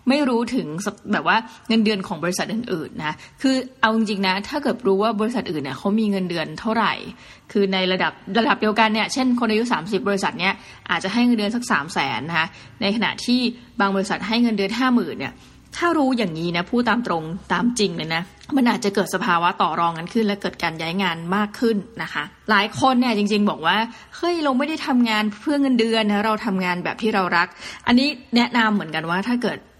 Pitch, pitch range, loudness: 215 Hz, 190-235 Hz, -21 LUFS